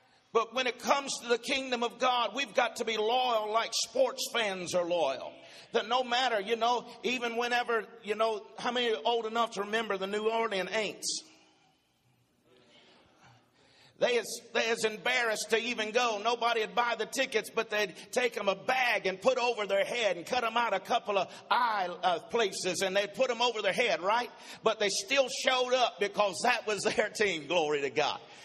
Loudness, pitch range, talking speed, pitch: -30 LUFS, 210-245 Hz, 195 wpm, 230 Hz